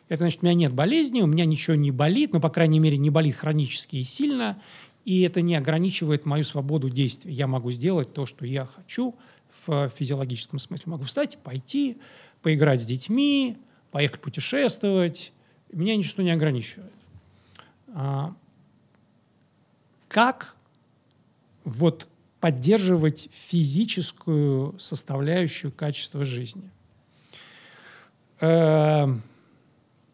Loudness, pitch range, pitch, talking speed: -24 LUFS, 140-180 Hz, 155 Hz, 115 wpm